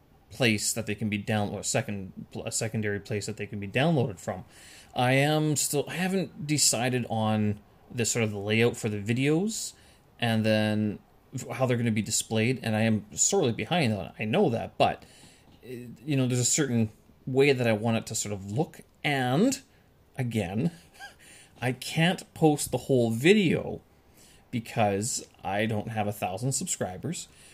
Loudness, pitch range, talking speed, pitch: -27 LUFS, 105-135 Hz, 175 wpm, 115 Hz